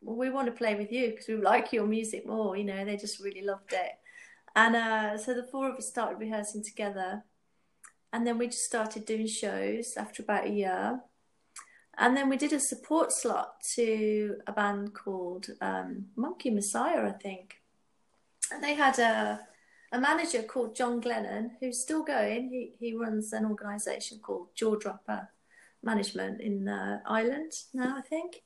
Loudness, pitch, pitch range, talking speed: -31 LUFS, 225 Hz, 210-250 Hz, 175 wpm